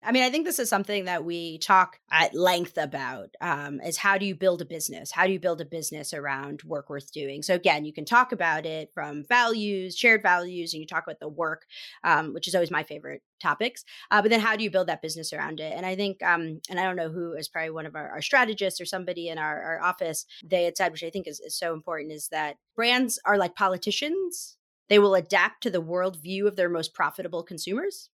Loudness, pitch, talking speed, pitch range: -26 LUFS, 175 Hz, 245 wpm, 160-200 Hz